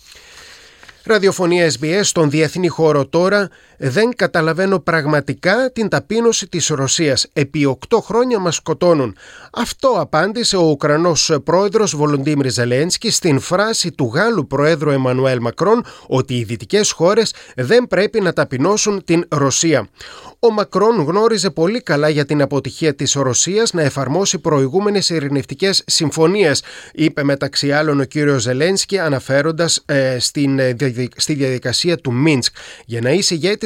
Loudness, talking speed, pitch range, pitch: -16 LUFS, 135 wpm, 140-190 Hz, 160 Hz